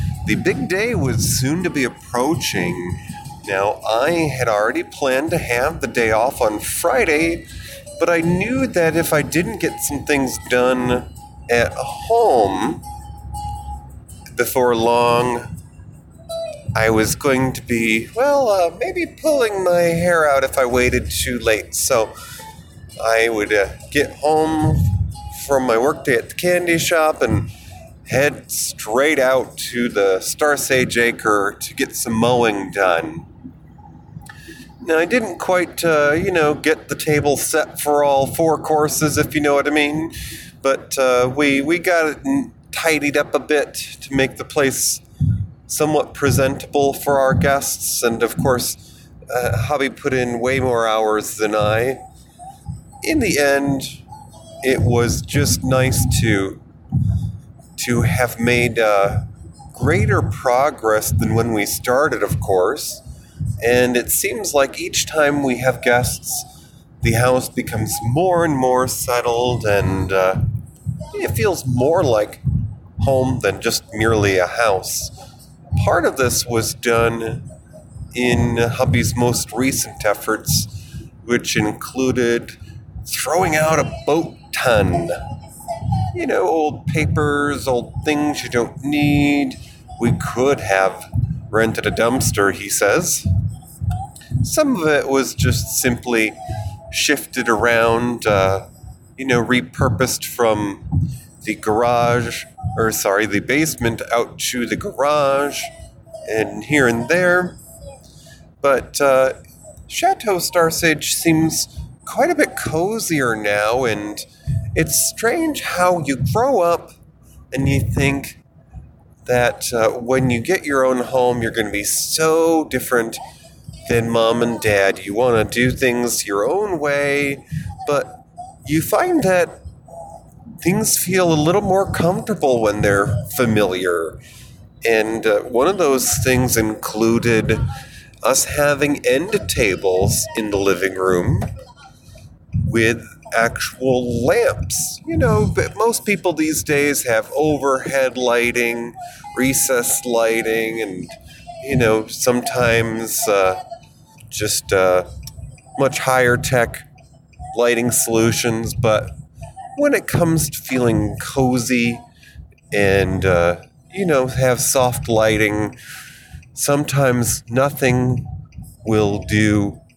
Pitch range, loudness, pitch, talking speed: 115-145 Hz, -18 LUFS, 125 Hz, 125 wpm